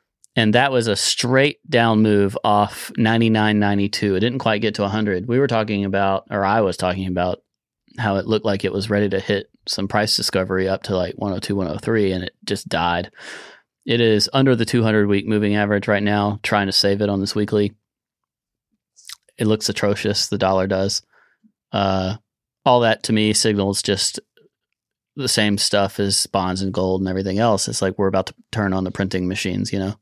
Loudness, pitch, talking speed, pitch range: -19 LUFS, 105 Hz, 195 wpm, 95-110 Hz